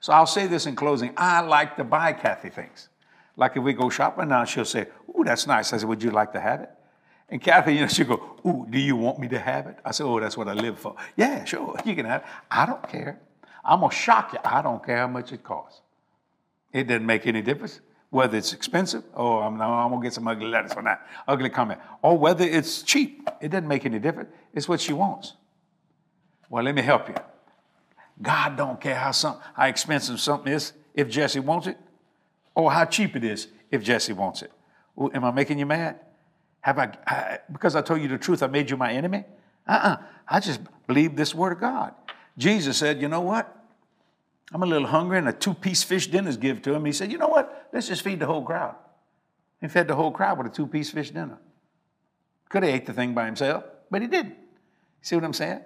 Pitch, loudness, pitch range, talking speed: 150 Hz, -24 LUFS, 130-175 Hz, 235 wpm